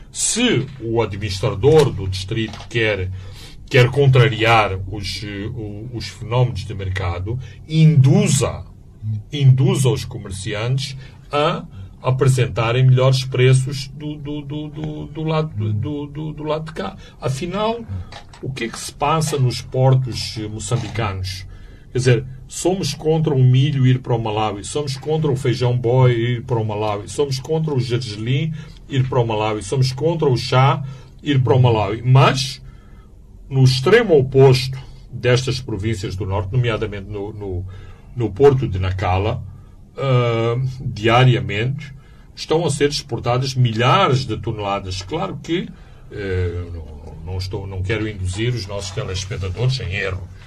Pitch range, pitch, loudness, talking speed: 105-135 Hz, 120 Hz, -19 LUFS, 135 wpm